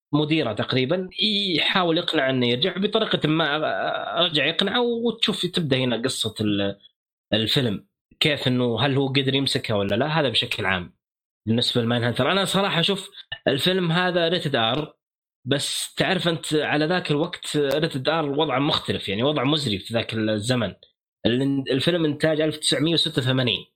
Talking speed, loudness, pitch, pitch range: 135 wpm, -22 LUFS, 150 Hz, 120-170 Hz